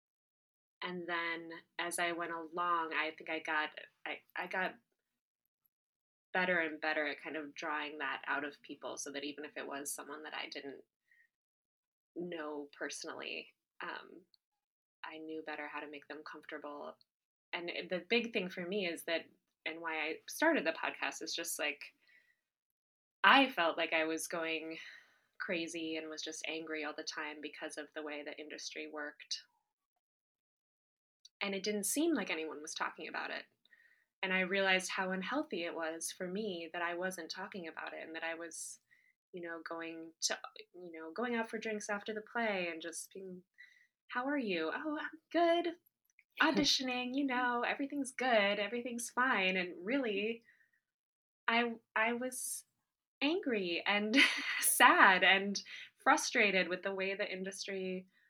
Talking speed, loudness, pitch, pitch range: 160 wpm, -36 LUFS, 185 Hz, 160-240 Hz